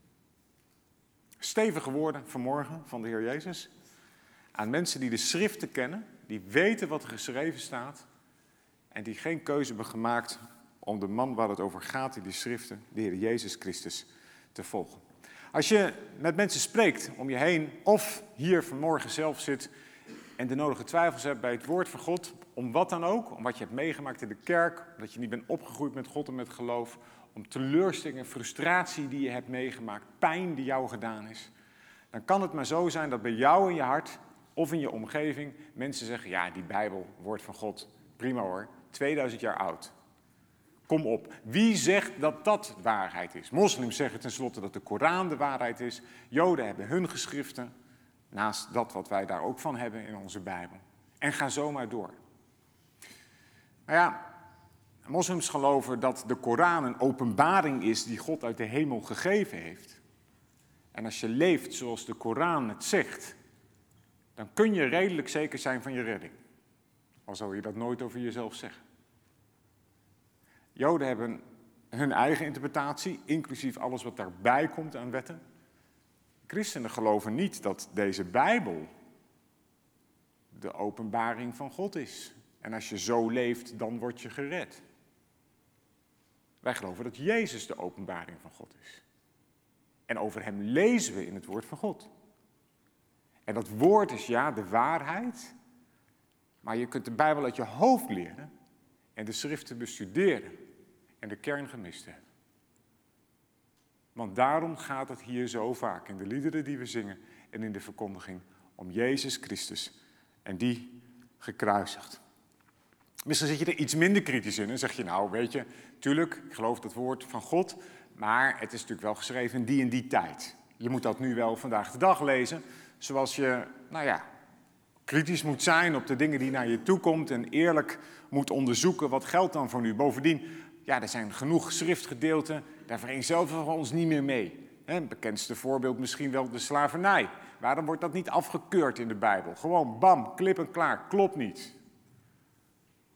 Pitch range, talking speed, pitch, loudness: 115-160 Hz, 170 wpm, 130 Hz, -31 LUFS